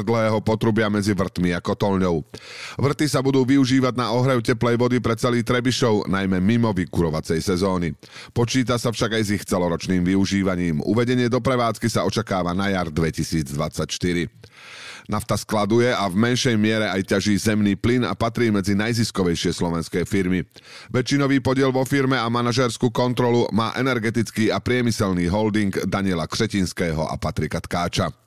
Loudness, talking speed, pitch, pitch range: -21 LUFS, 150 wpm, 110 Hz, 95-120 Hz